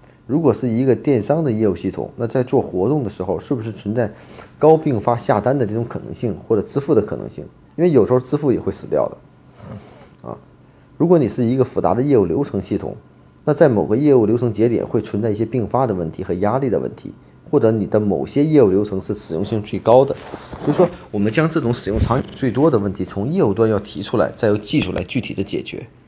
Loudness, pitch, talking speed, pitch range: -18 LUFS, 115 Hz, 345 characters per minute, 105-135 Hz